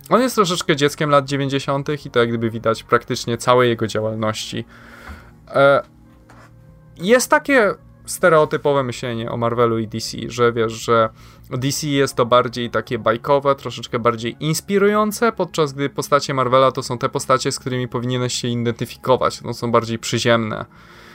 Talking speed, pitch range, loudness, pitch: 145 wpm, 115-145 Hz, -19 LUFS, 125 Hz